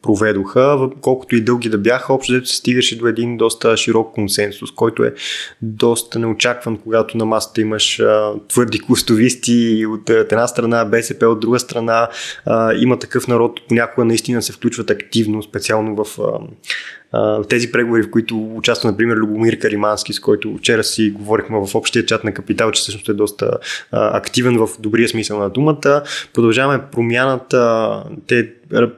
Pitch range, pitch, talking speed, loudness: 110-120 Hz, 115 Hz, 155 wpm, -16 LUFS